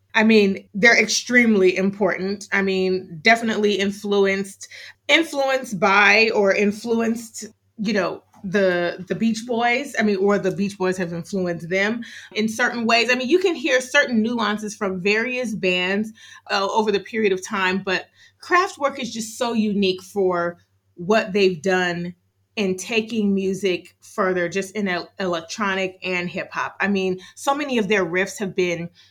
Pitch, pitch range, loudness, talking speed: 200 Hz, 185-225 Hz, -20 LUFS, 155 wpm